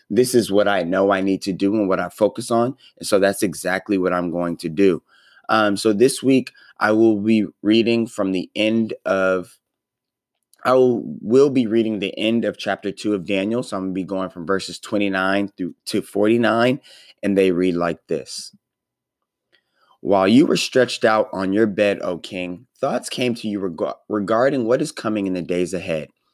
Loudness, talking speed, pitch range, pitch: -20 LUFS, 200 wpm, 95-115 Hz, 100 Hz